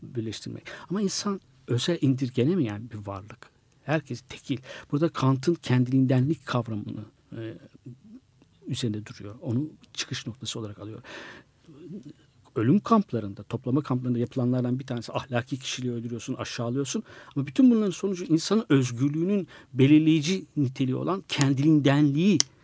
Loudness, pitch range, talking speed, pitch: -26 LUFS, 120-155 Hz, 115 wpm, 135 Hz